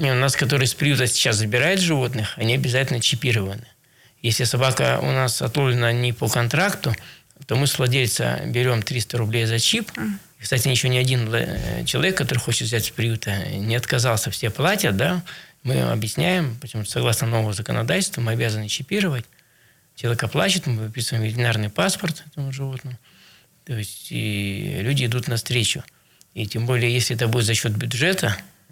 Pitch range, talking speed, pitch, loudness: 115-135 Hz, 160 wpm, 125 Hz, -21 LUFS